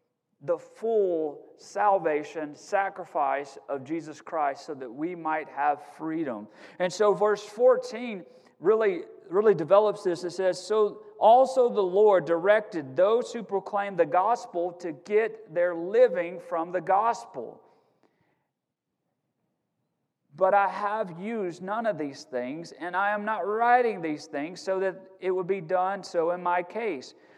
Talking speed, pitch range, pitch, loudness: 140 wpm, 170-215 Hz, 190 Hz, -27 LUFS